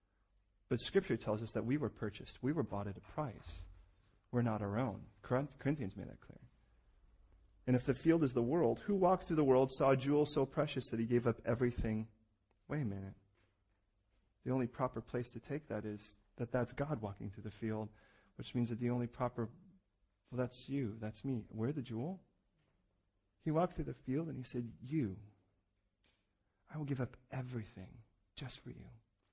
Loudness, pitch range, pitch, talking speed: -39 LUFS, 105-130 Hz, 115 Hz, 190 wpm